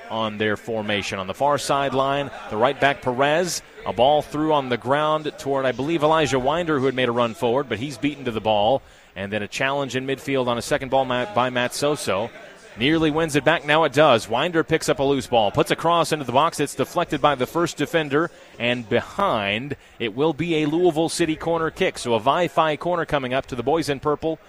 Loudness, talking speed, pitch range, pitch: -22 LUFS, 230 wpm, 125-155 Hz, 140 Hz